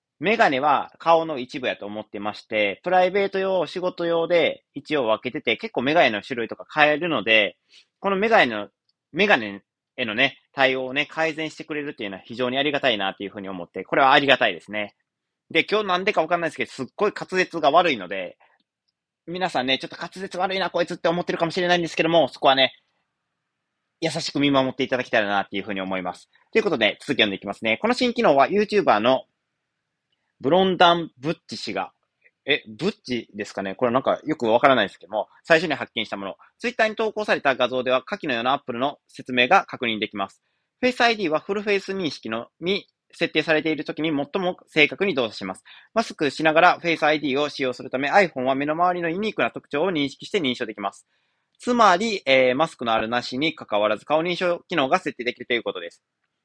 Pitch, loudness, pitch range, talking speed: 150 Hz, -22 LUFS, 125-180 Hz, 455 characters per minute